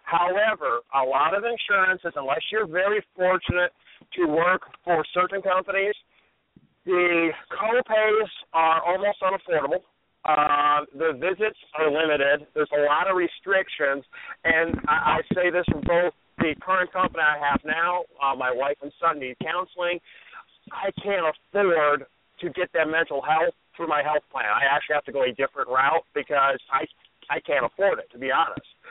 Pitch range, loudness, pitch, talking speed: 150-185 Hz, -24 LUFS, 170 Hz, 160 wpm